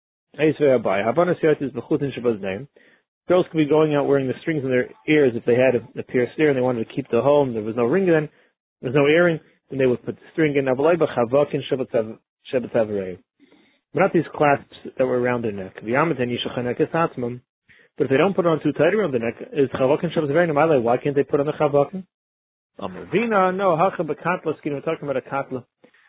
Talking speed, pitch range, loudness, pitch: 170 wpm, 120-155 Hz, -21 LUFS, 140 Hz